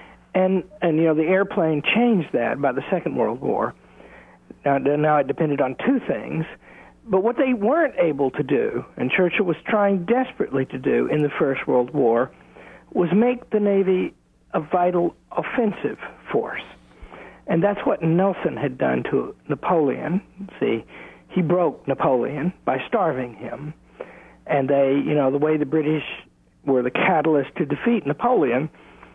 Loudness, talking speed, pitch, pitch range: -22 LUFS, 155 wpm, 160 Hz, 140-195 Hz